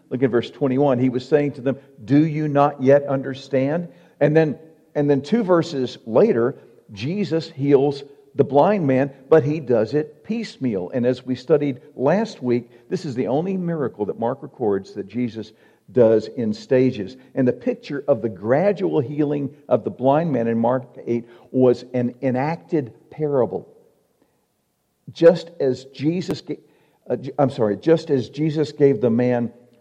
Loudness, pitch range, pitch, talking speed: -21 LUFS, 125-155 Hz, 140 Hz, 165 wpm